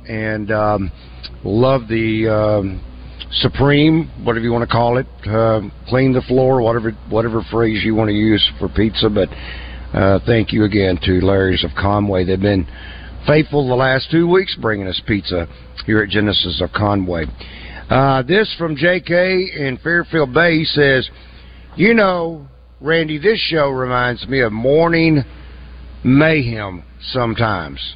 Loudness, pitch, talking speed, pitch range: -16 LUFS, 110 Hz, 150 wpm, 95-135 Hz